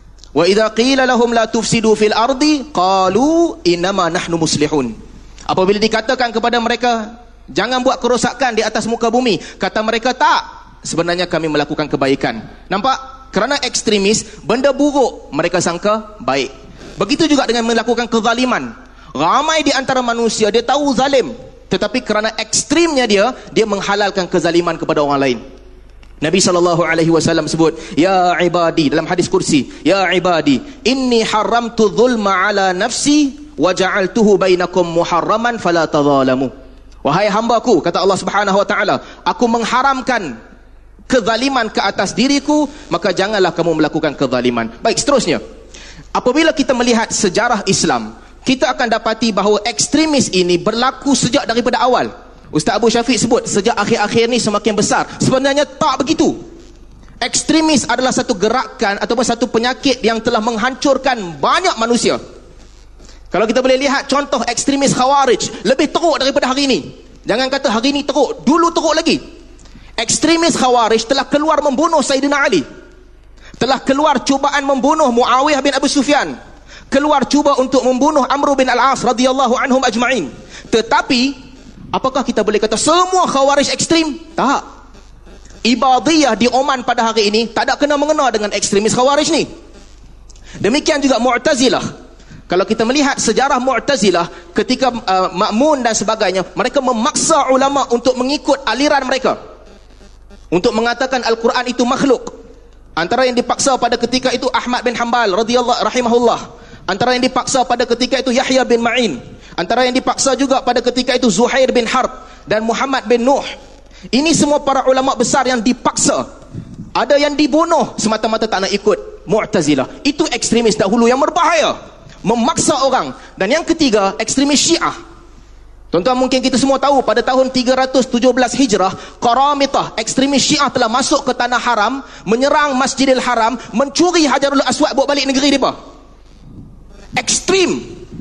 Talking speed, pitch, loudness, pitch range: 140 wpm, 245 Hz, -14 LUFS, 210-275 Hz